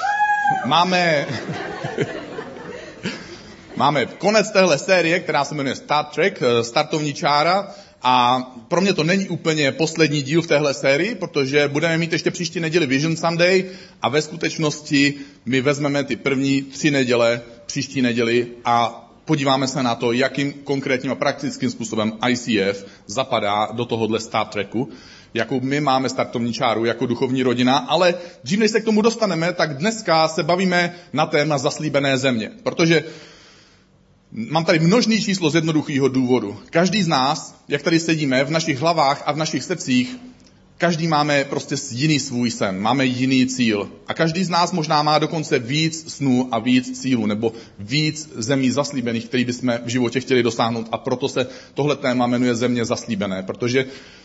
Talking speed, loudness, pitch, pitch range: 155 wpm, -20 LUFS, 140 Hz, 125-165 Hz